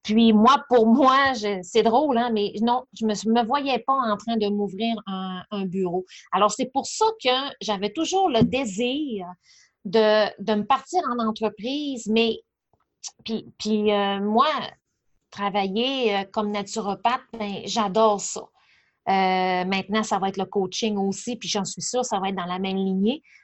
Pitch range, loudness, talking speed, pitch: 200-245 Hz, -23 LUFS, 175 wpm, 215 Hz